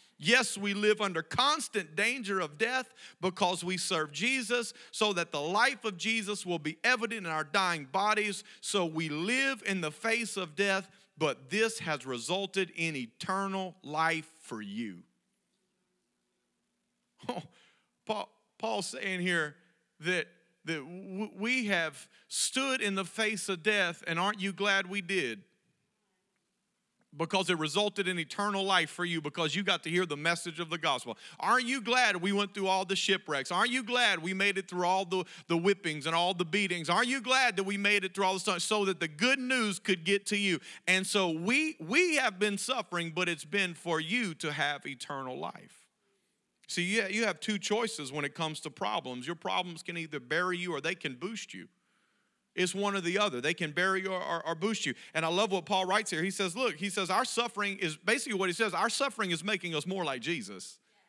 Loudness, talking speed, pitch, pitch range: -31 LUFS, 200 wpm, 190 Hz, 170-210 Hz